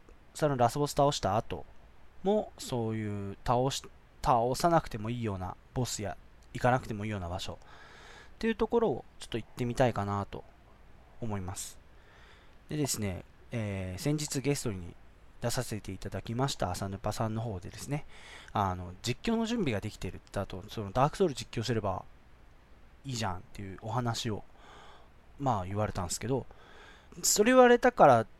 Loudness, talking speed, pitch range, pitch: -31 LUFS, 335 characters per minute, 95-130 Hz, 110 Hz